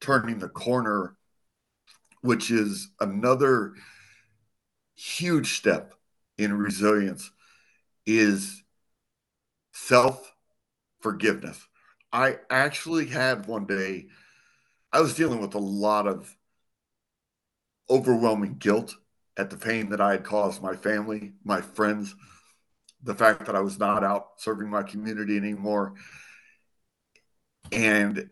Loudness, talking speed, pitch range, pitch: -26 LUFS, 105 wpm, 100-115 Hz, 105 Hz